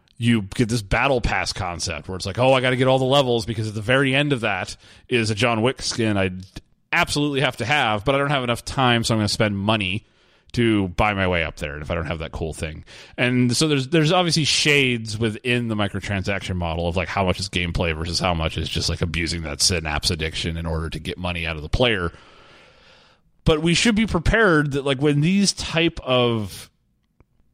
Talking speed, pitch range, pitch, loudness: 230 wpm, 90-130 Hz, 110 Hz, -21 LUFS